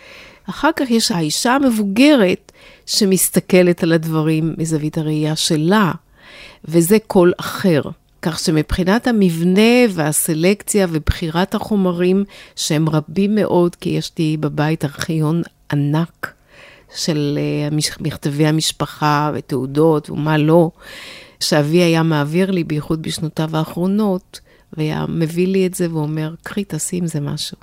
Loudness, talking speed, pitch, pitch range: -17 LUFS, 115 wpm, 165 Hz, 155-190 Hz